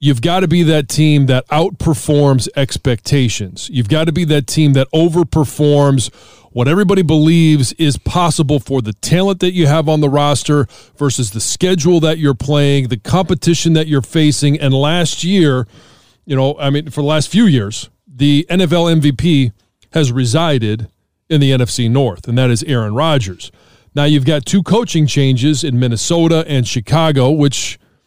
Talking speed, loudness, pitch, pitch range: 170 wpm, -13 LUFS, 145 Hz, 130-160 Hz